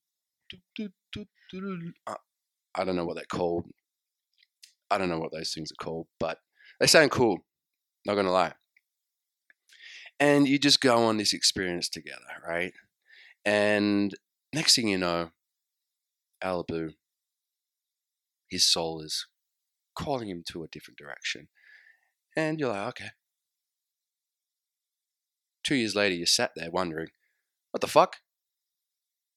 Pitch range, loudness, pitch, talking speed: 85-135 Hz, -27 LUFS, 95 Hz, 120 wpm